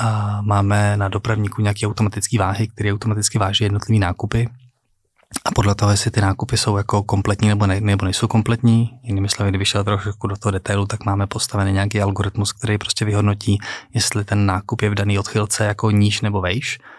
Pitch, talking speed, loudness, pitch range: 105 Hz, 185 wpm, -19 LUFS, 100-110 Hz